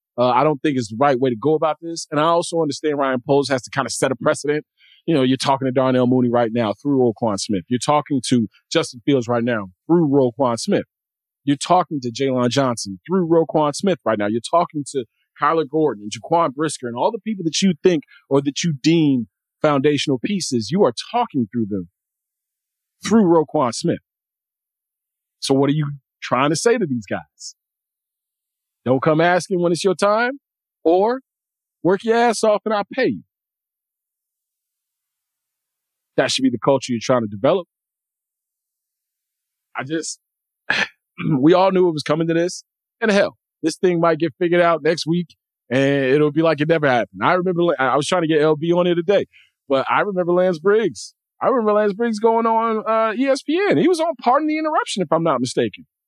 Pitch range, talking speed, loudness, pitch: 130-185 Hz, 195 wpm, -19 LUFS, 155 Hz